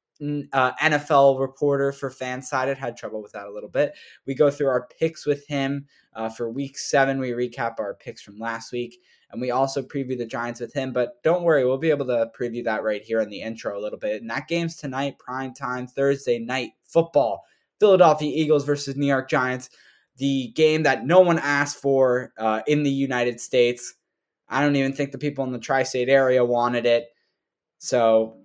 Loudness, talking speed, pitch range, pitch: -23 LUFS, 200 wpm, 120-145 Hz, 135 Hz